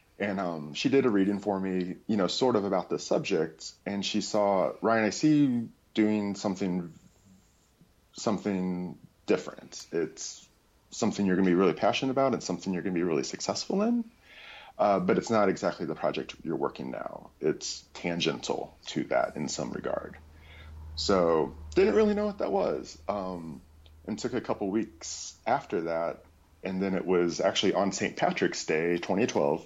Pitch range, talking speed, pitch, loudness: 85-105 Hz, 175 wpm, 95 Hz, -29 LUFS